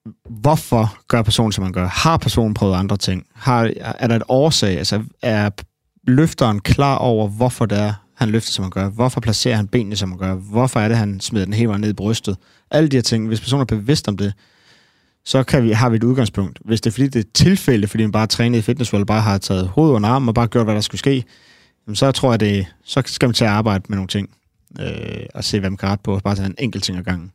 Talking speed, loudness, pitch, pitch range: 265 wpm, -18 LUFS, 110 Hz, 100-125 Hz